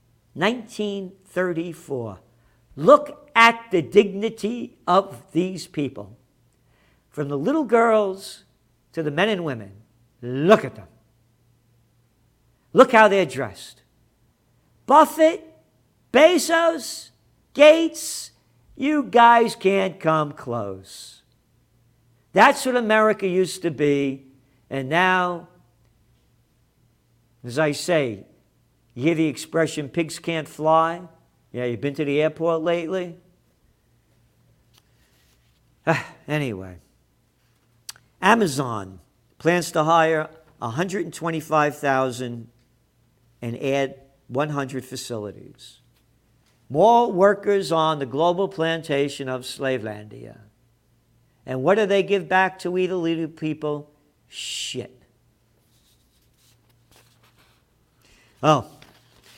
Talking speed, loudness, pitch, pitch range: 90 wpm, -21 LUFS, 145 Hz, 120-185 Hz